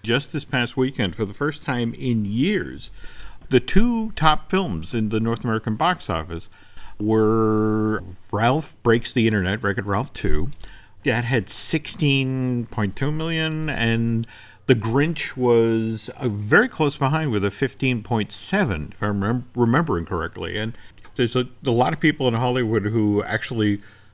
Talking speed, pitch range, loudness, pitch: 145 wpm, 105-135 Hz, -22 LUFS, 115 Hz